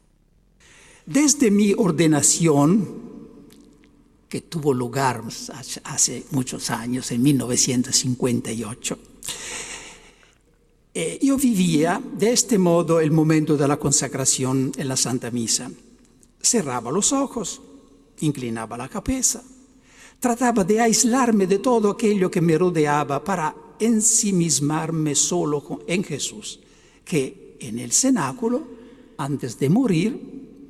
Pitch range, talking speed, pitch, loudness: 140-230 Hz, 105 wpm, 170 Hz, -21 LUFS